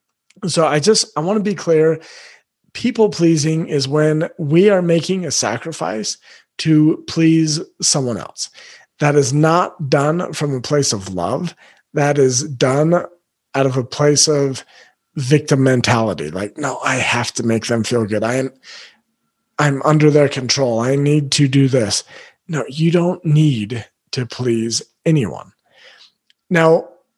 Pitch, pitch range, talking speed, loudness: 145 Hz, 130-160 Hz, 150 wpm, -16 LUFS